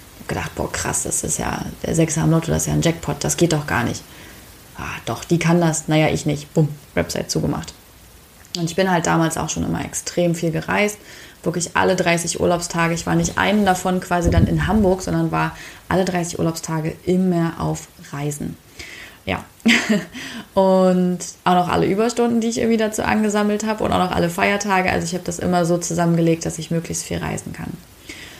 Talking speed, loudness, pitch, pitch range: 195 wpm, -20 LUFS, 170 Hz, 160-185 Hz